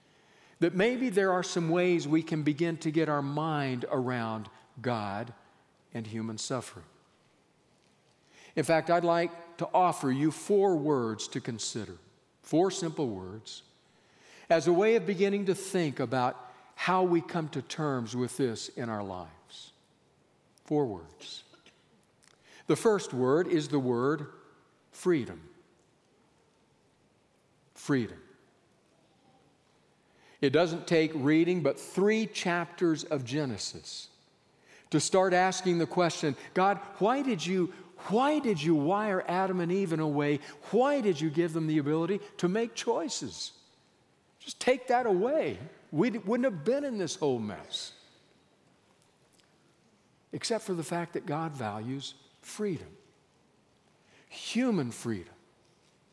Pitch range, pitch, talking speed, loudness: 135-185 Hz, 165 Hz, 130 wpm, -30 LUFS